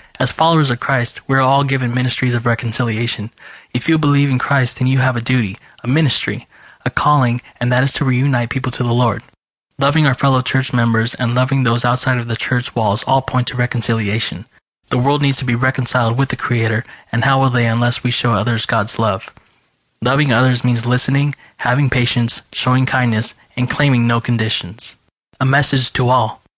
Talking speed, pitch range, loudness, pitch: 195 wpm, 120-135 Hz, -16 LUFS, 125 Hz